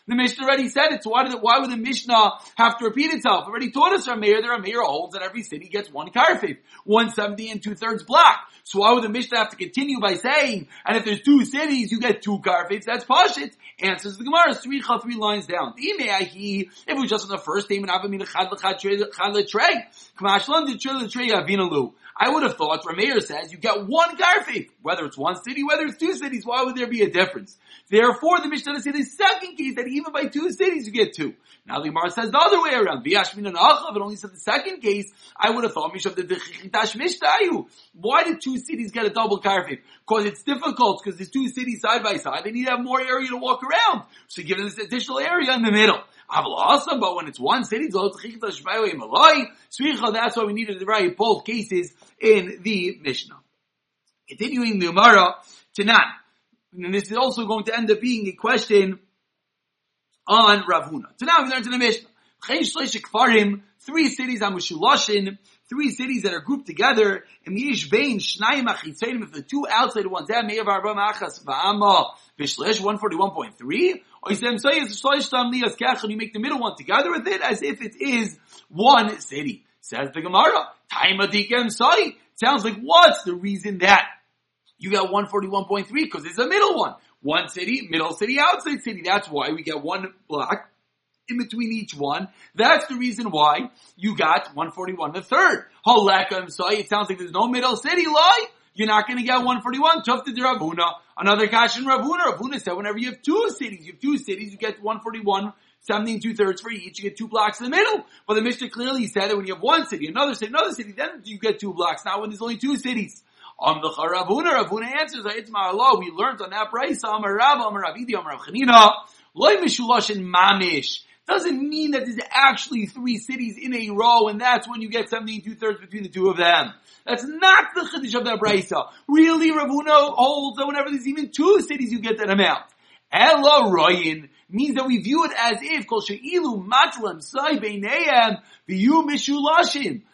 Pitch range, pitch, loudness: 205-275 Hz, 230 Hz, -20 LUFS